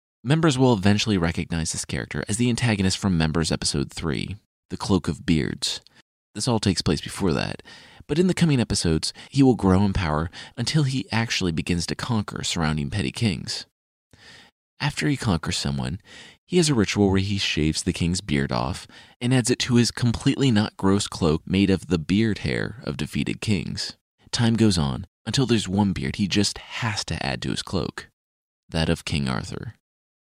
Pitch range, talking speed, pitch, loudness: 85-115 Hz, 185 wpm, 100 Hz, -23 LUFS